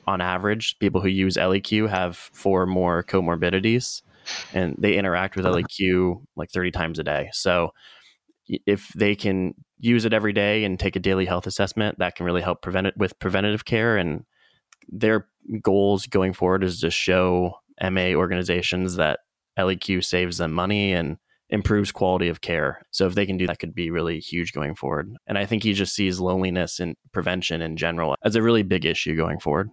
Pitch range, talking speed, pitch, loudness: 90-100 Hz, 190 wpm, 95 Hz, -23 LUFS